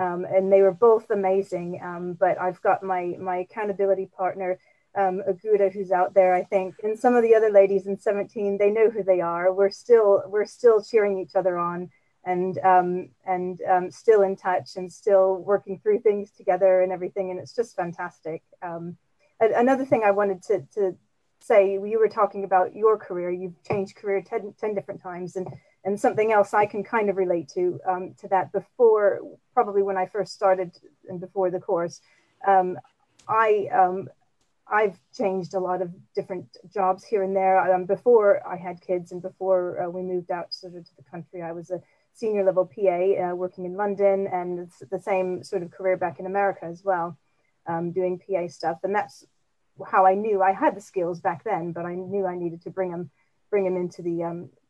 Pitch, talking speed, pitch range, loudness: 190 Hz, 200 wpm, 180-200 Hz, -24 LUFS